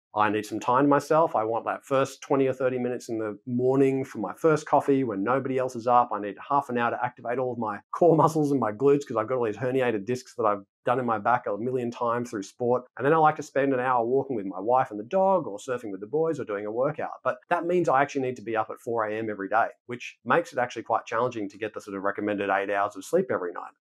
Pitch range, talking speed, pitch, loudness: 110-140 Hz, 290 wpm, 125 Hz, -26 LUFS